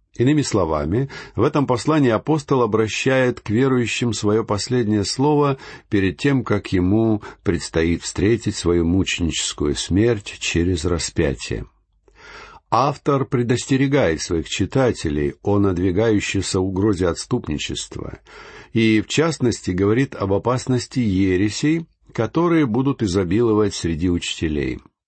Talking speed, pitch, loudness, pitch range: 105 wpm, 110 Hz, -20 LUFS, 95-130 Hz